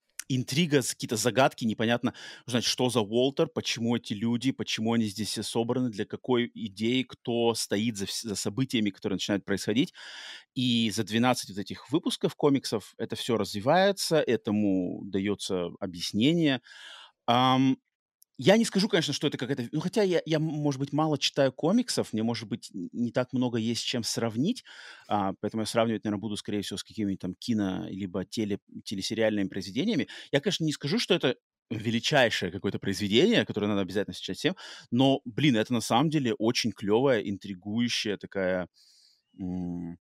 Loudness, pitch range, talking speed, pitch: -28 LUFS, 105-135 Hz, 155 wpm, 115 Hz